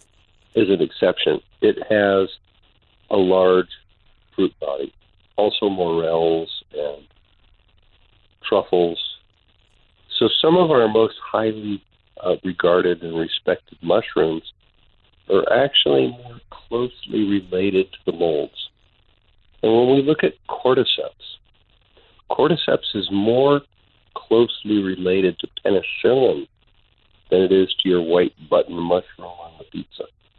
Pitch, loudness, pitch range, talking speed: 95 Hz, -19 LUFS, 90-110 Hz, 110 wpm